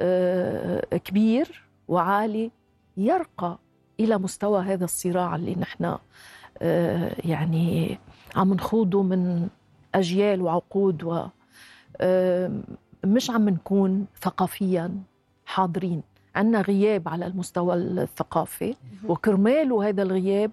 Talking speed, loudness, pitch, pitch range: 80 wpm, -25 LUFS, 190 Hz, 180-205 Hz